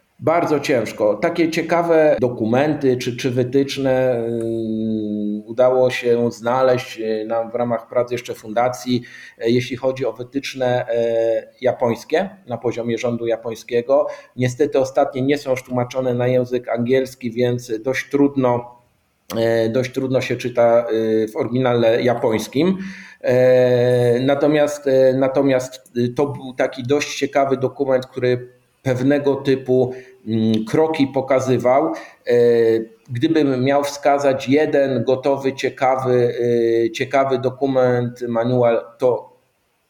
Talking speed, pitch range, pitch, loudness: 100 wpm, 120-135 Hz, 125 Hz, -19 LUFS